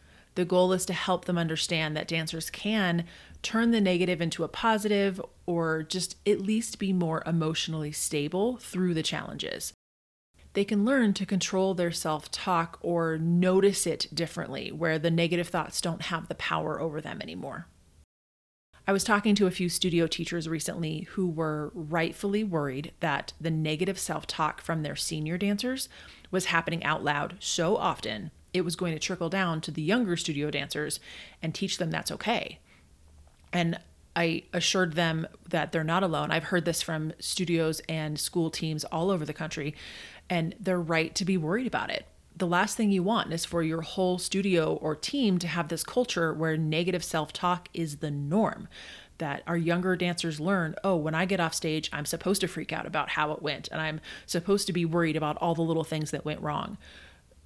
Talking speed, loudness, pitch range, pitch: 185 wpm, -29 LUFS, 155-185 Hz, 170 Hz